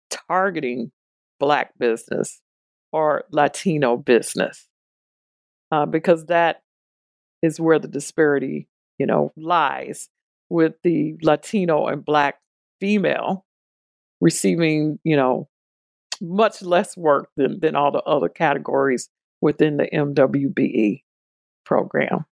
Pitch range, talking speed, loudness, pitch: 135-165 Hz, 100 wpm, -21 LUFS, 150 Hz